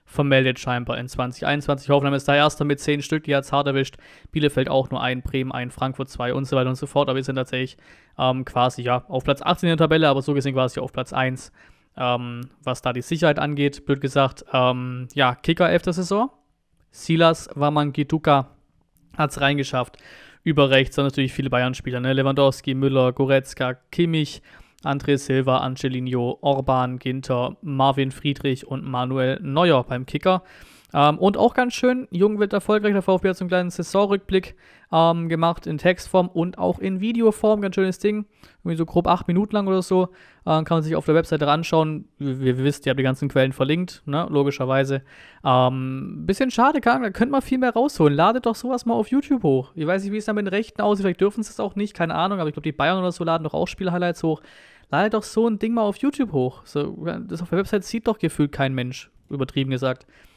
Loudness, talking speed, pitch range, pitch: -22 LUFS, 210 wpm, 130-185 Hz, 145 Hz